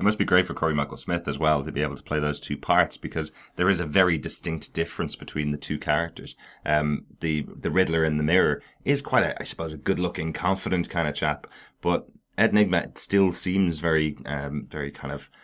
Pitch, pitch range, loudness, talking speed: 80 Hz, 75-95 Hz, -26 LUFS, 220 wpm